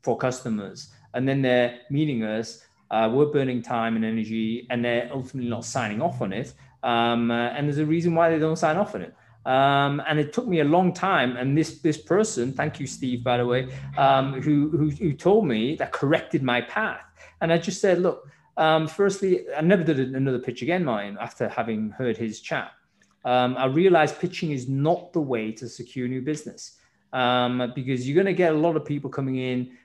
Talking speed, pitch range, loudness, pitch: 210 wpm, 125-160 Hz, -24 LUFS, 135 Hz